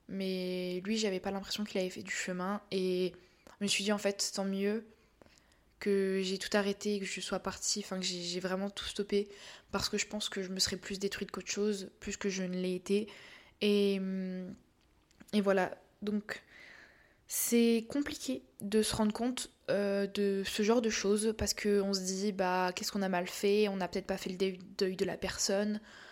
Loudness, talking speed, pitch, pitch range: -34 LUFS, 205 wpm, 200 Hz, 190-210 Hz